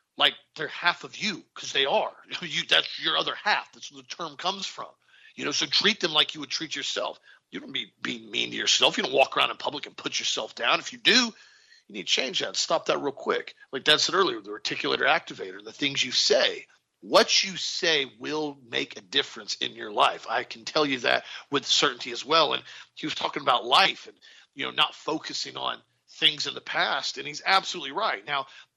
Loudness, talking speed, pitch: -25 LUFS, 225 wpm, 175 Hz